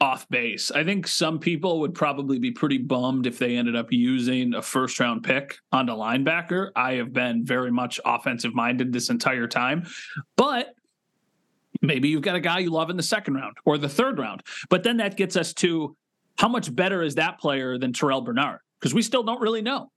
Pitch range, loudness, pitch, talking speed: 130-190 Hz, -24 LUFS, 155 Hz, 210 wpm